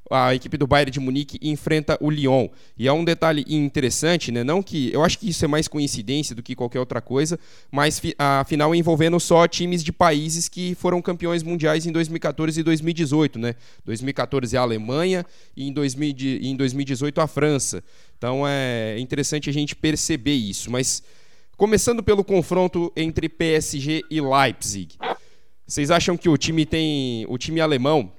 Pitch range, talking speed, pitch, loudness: 135-165 Hz, 165 wpm, 150 Hz, -22 LUFS